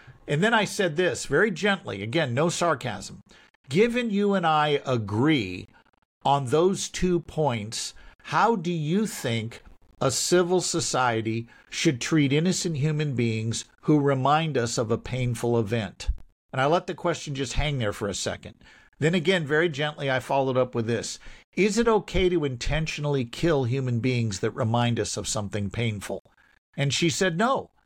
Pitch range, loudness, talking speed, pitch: 120-175 Hz, -25 LUFS, 165 wpm, 145 Hz